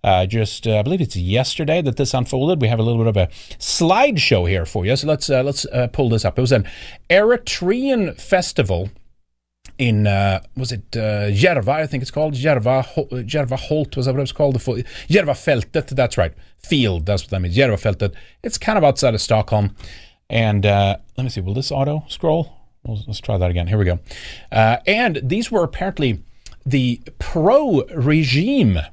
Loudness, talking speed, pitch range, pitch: -18 LUFS, 190 wpm, 105-140 Hz, 125 Hz